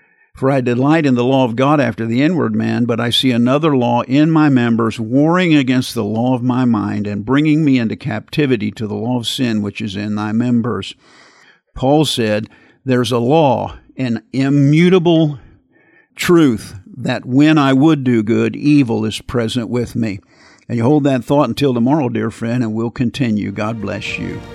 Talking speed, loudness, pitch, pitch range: 185 wpm, -15 LUFS, 120 Hz, 110-140 Hz